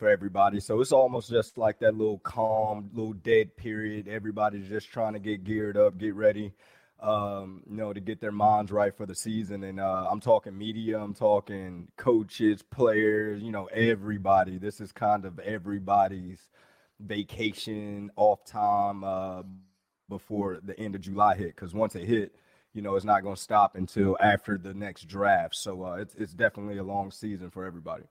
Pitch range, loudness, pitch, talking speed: 100-110 Hz, -28 LUFS, 105 Hz, 185 wpm